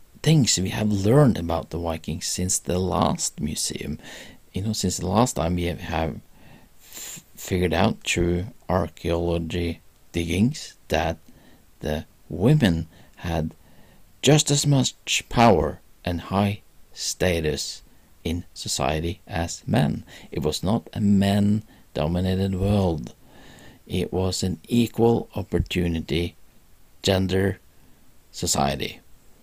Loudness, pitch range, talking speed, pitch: -24 LUFS, 85-105 Hz, 110 wpm, 90 Hz